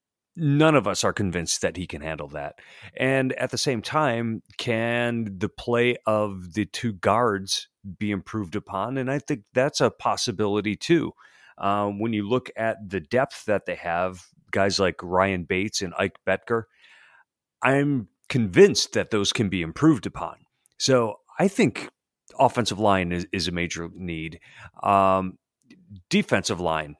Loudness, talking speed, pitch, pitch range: -24 LUFS, 155 wpm, 105 Hz, 95-120 Hz